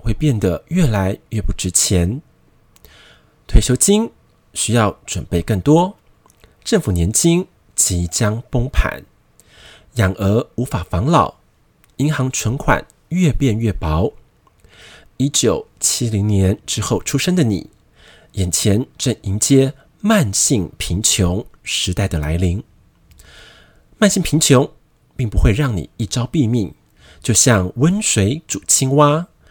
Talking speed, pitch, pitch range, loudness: 175 characters per minute, 115 Hz, 95-140 Hz, -17 LUFS